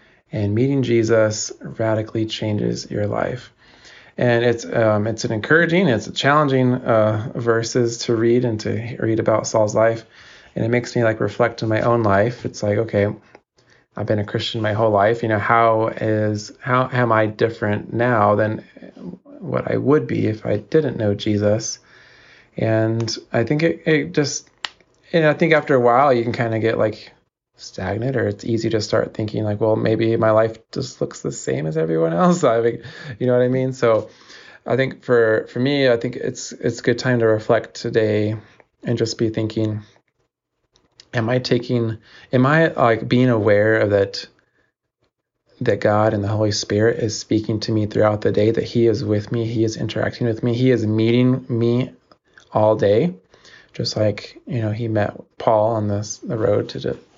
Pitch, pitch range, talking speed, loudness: 115 Hz, 110-120 Hz, 190 wpm, -19 LUFS